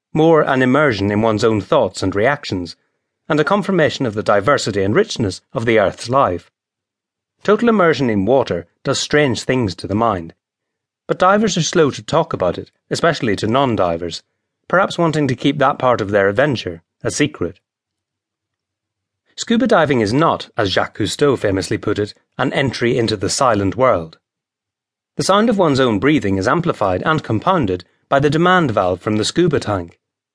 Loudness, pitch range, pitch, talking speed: -16 LUFS, 105-155 Hz, 125 Hz, 170 wpm